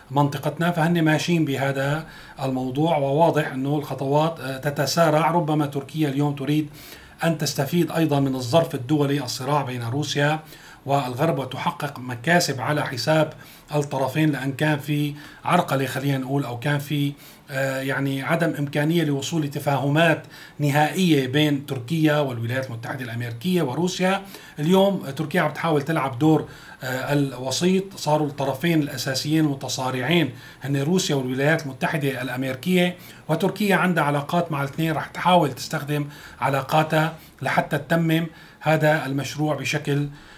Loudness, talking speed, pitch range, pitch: -23 LUFS, 115 wpm, 140-160 Hz, 150 Hz